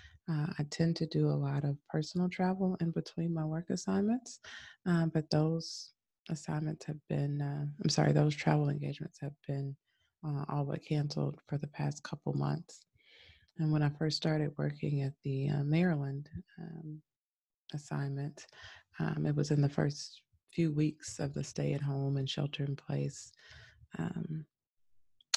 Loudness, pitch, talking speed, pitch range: -35 LUFS, 150 Hz, 160 wpm, 140-165 Hz